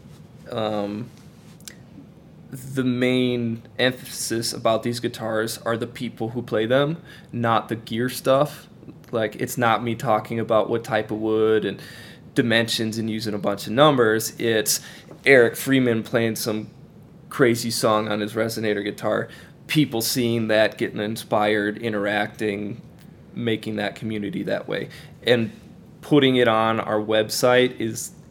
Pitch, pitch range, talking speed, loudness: 115 Hz, 110-125 Hz, 135 wpm, -22 LUFS